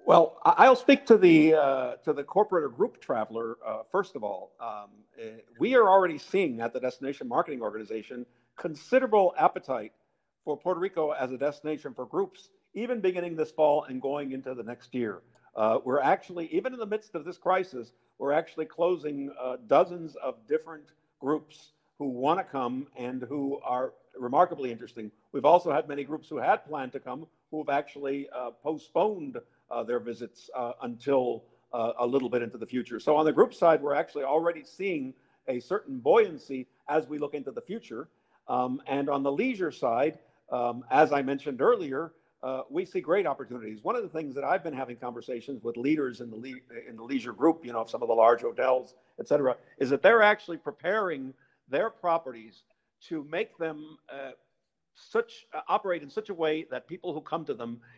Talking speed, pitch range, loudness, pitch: 190 wpm, 125-175 Hz, -28 LUFS, 145 Hz